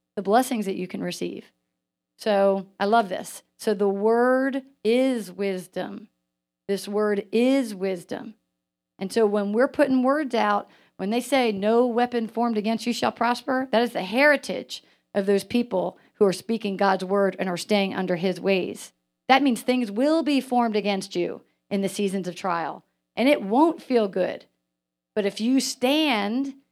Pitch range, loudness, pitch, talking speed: 190-245 Hz, -24 LUFS, 210 Hz, 170 wpm